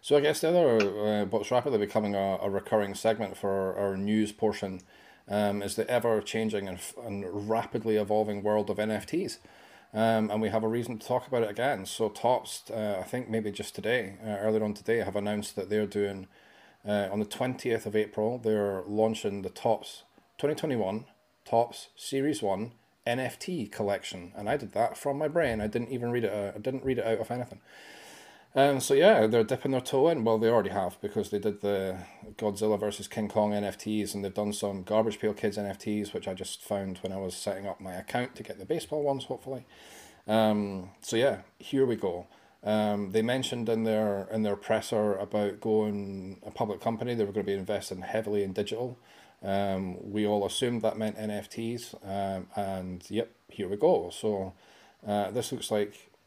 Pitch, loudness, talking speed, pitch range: 105 Hz, -30 LUFS, 200 wpm, 100-115 Hz